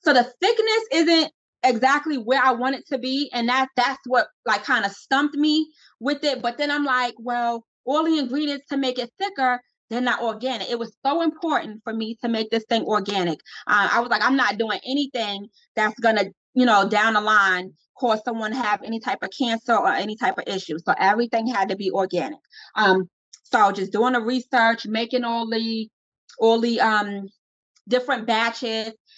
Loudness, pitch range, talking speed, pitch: -22 LUFS, 215-265 Hz, 195 wpm, 240 Hz